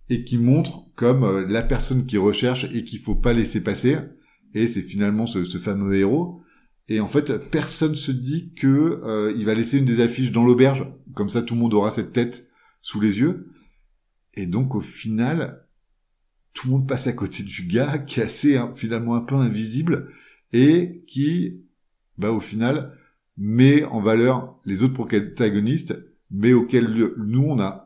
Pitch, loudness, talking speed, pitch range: 120 Hz, -21 LUFS, 180 wpm, 110-135 Hz